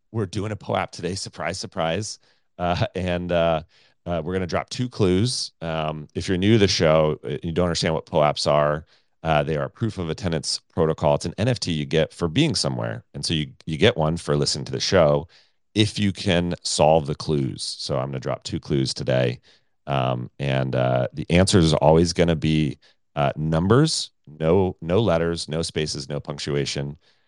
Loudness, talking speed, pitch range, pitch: -23 LUFS, 200 wpm, 75-95 Hz, 80 Hz